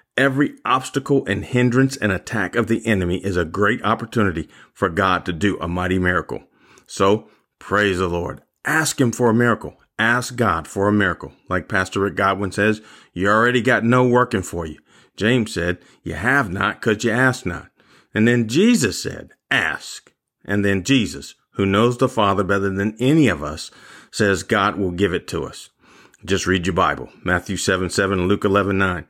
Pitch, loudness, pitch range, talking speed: 100 Hz, -19 LUFS, 95-120 Hz, 185 wpm